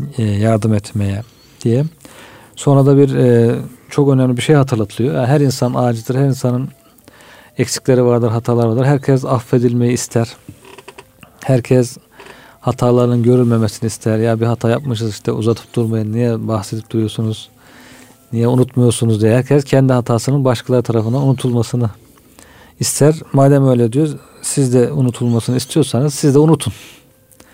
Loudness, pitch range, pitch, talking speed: -15 LUFS, 115-135 Hz, 125 Hz, 125 wpm